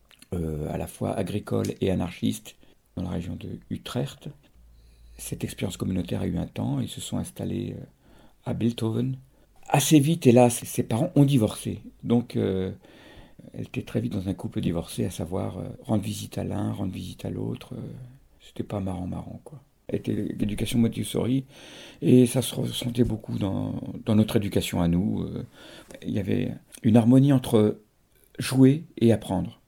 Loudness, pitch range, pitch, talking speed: -26 LUFS, 95-125 Hz, 110 Hz, 170 wpm